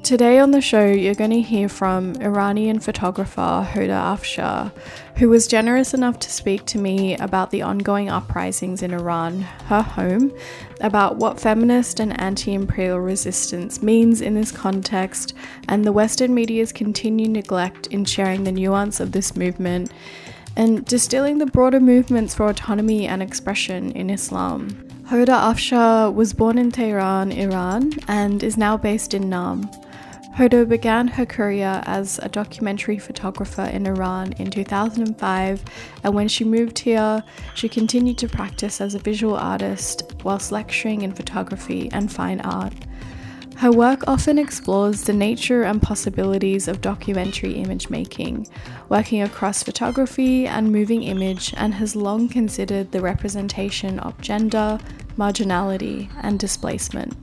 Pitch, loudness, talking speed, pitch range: 210 Hz, -20 LUFS, 145 wpm, 195-230 Hz